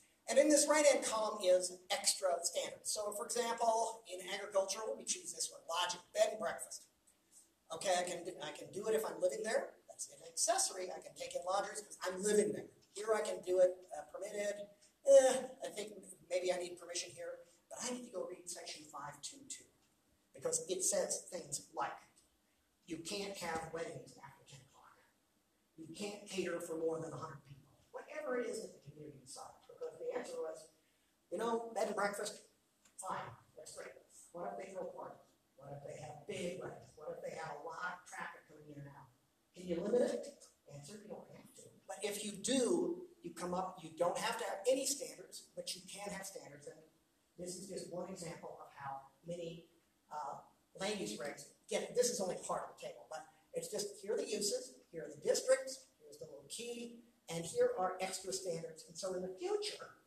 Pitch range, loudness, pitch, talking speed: 175-270 Hz, -39 LUFS, 195 Hz, 200 wpm